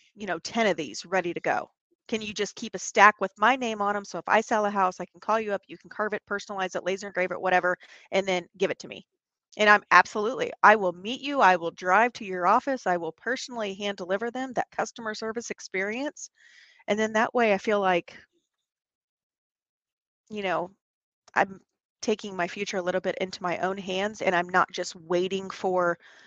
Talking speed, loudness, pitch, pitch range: 215 wpm, -26 LUFS, 200 Hz, 180-220 Hz